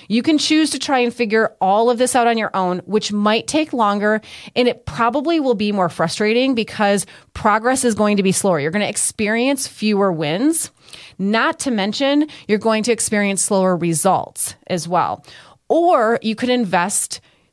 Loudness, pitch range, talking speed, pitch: -17 LUFS, 200-250 Hz, 180 wpm, 220 Hz